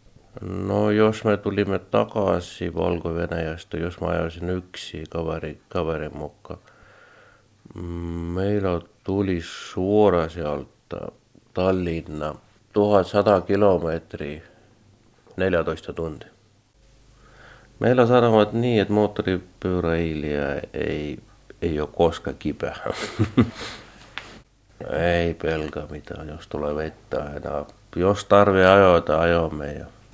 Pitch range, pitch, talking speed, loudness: 80-100 Hz, 90 Hz, 85 wpm, -23 LUFS